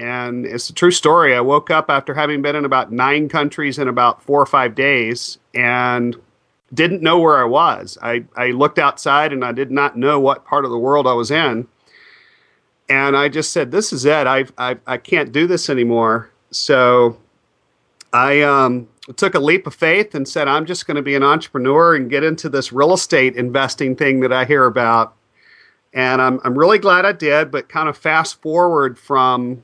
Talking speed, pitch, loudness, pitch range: 200 wpm, 140 Hz, -15 LUFS, 125-155 Hz